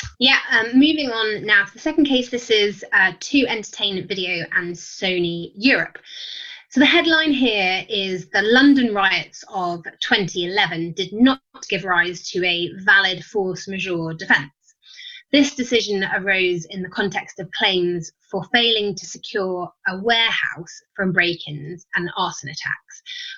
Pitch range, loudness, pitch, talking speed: 180-245 Hz, -19 LUFS, 195 Hz, 150 wpm